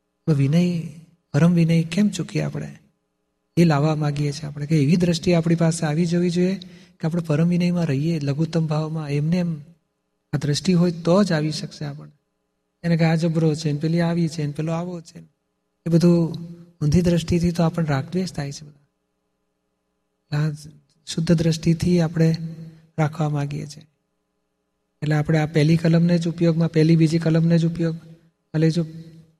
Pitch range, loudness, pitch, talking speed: 150-170 Hz, -21 LUFS, 160 Hz, 160 wpm